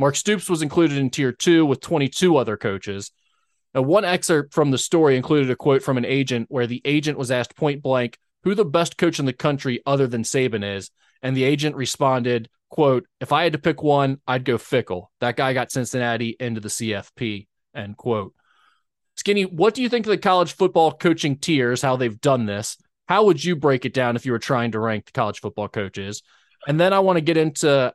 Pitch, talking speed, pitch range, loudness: 135 Hz, 220 wpm, 120-155 Hz, -21 LUFS